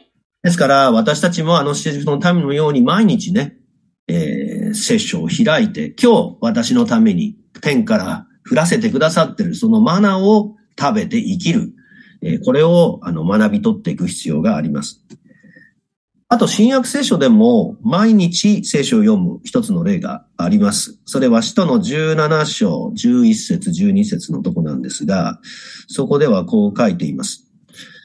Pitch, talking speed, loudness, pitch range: 215 Hz, 295 characters per minute, -15 LUFS, 185-230 Hz